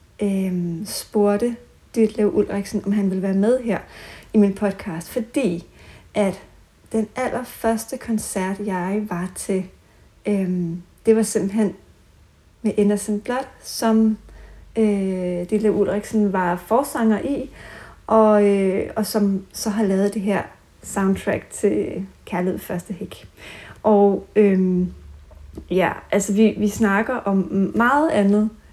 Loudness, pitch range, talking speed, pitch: -21 LUFS, 190-220 Hz, 125 wpm, 205 Hz